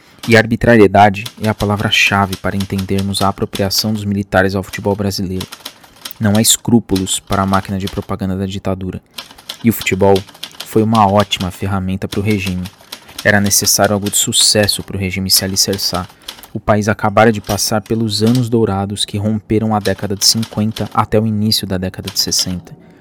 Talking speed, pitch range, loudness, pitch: 170 wpm, 95-110 Hz, -14 LUFS, 100 Hz